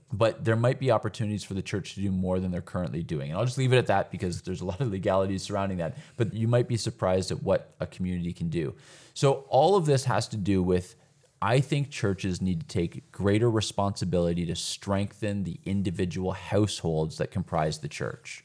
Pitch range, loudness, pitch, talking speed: 95-120 Hz, -28 LUFS, 100 Hz, 215 wpm